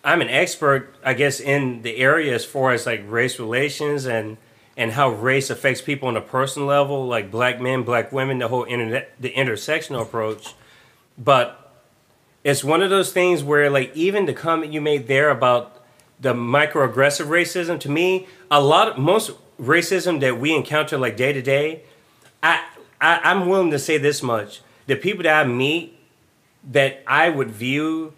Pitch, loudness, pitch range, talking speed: 140 Hz, -20 LUFS, 125-155 Hz, 175 wpm